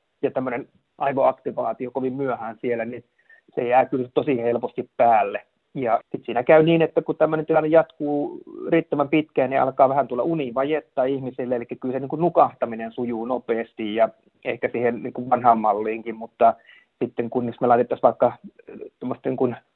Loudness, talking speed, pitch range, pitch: -22 LUFS, 160 wpm, 120-155 Hz, 130 Hz